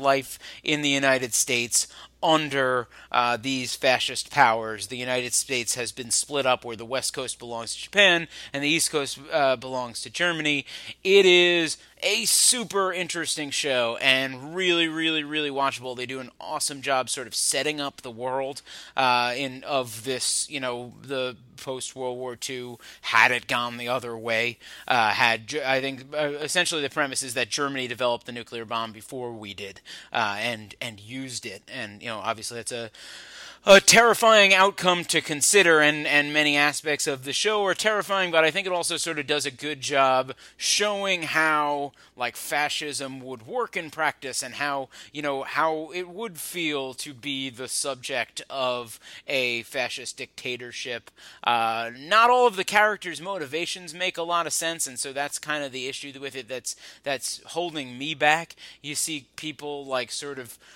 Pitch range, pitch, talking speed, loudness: 125-155 Hz, 140 Hz, 180 wpm, -24 LUFS